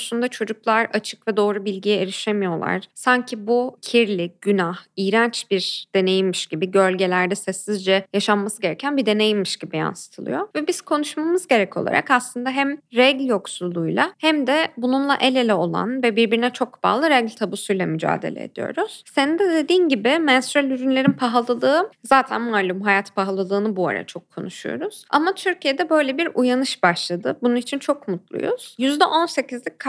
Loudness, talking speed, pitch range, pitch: -20 LUFS, 145 wpm, 195-275 Hz, 240 Hz